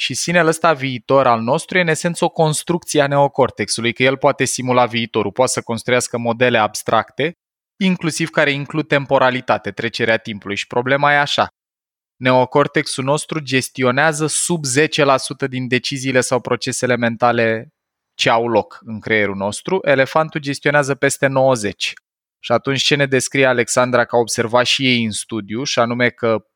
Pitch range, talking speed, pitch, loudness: 120-145 Hz, 155 wpm, 130 Hz, -17 LUFS